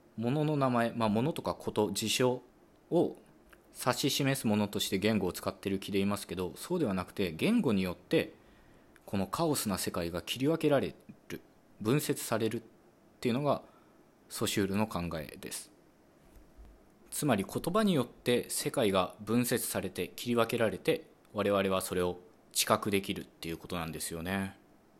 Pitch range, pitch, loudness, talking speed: 95-120 Hz, 105 Hz, -32 LUFS, 320 characters per minute